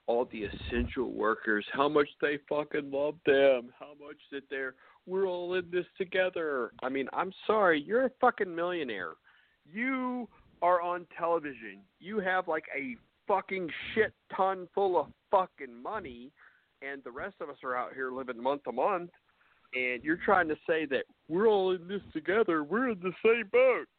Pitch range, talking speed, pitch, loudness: 140-200 Hz, 175 wpm, 180 Hz, -31 LUFS